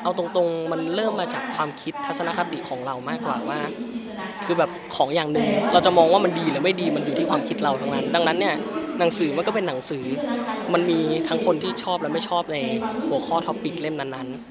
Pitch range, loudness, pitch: 160-220 Hz, -23 LUFS, 170 Hz